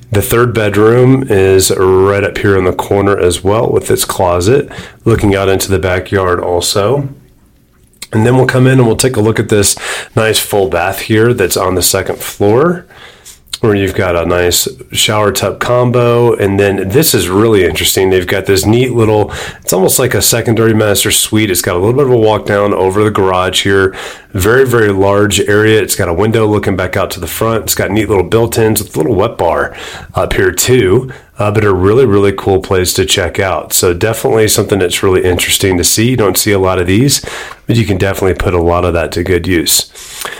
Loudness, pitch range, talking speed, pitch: -10 LUFS, 95-110 Hz, 215 wpm, 100 Hz